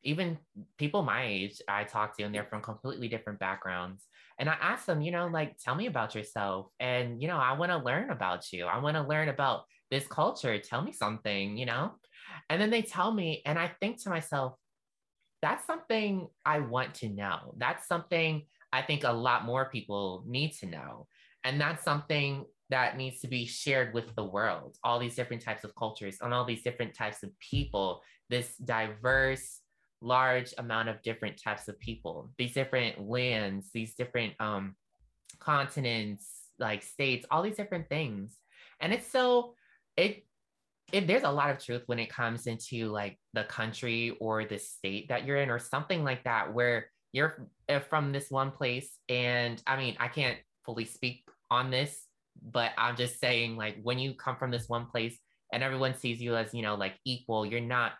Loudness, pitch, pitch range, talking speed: -32 LUFS, 125 Hz, 115-145 Hz, 190 wpm